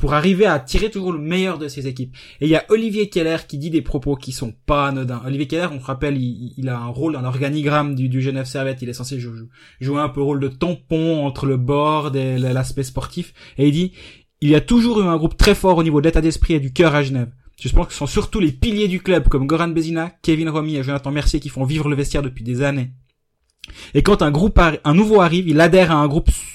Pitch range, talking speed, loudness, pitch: 135-165 Hz, 265 wpm, -18 LUFS, 145 Hz